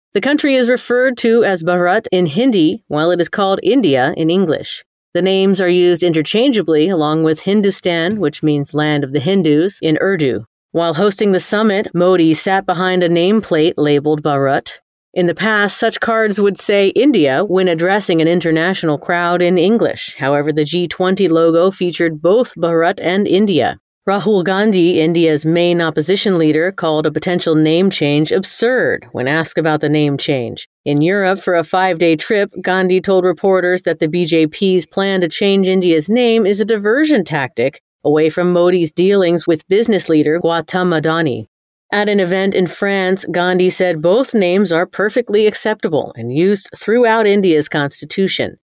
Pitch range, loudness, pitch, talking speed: 160-195 Hz, -14 LUFS, 180 Hz, 165 wpm